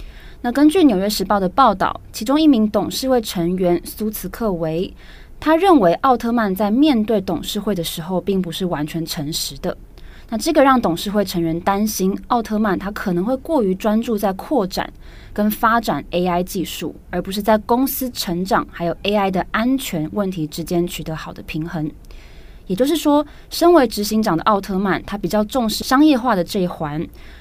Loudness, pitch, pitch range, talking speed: -18 LUFS, 205 Hz, 175-235 Hz, 280 characters per minute